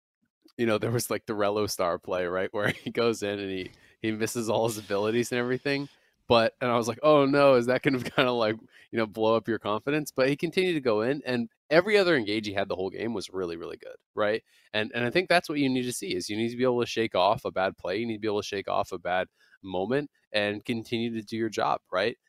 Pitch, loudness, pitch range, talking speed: 120 Hz, -27 LUFS, 110-140 Hz, 275 wpm